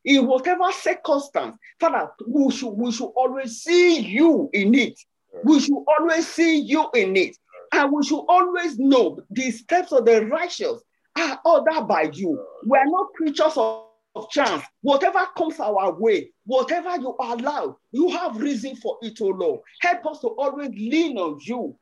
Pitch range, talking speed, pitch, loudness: 250-345 Hz, 165 wpm, 290 Hz, -21 LUFS